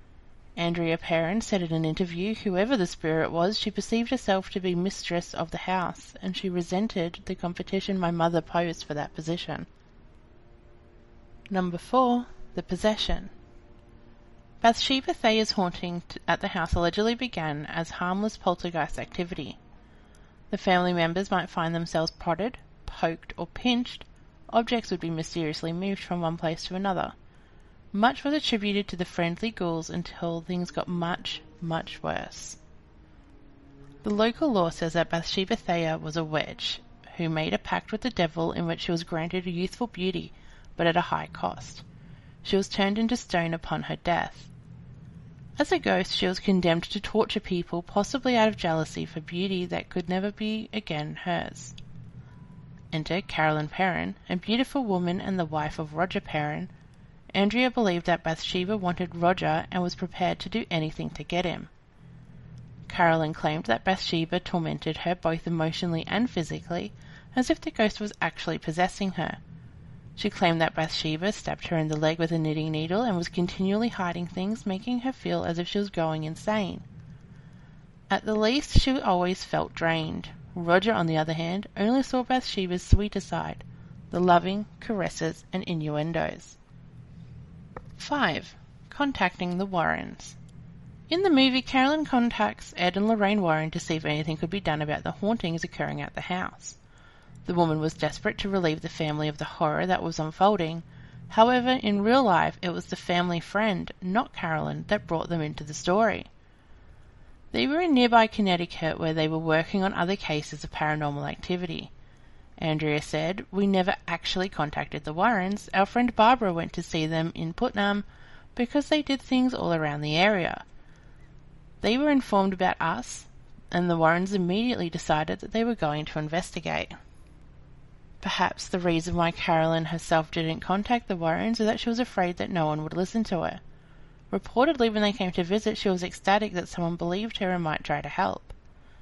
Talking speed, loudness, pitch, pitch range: 165 wpm, -27 LUFS, 180 Hz, 160-205 Hz